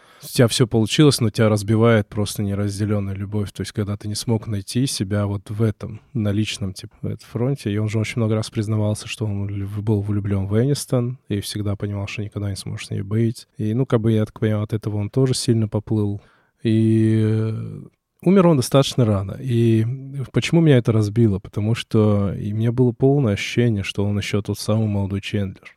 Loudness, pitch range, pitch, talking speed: -21 LUFS, 105-120 Hz, 110 Hz, 205 wpm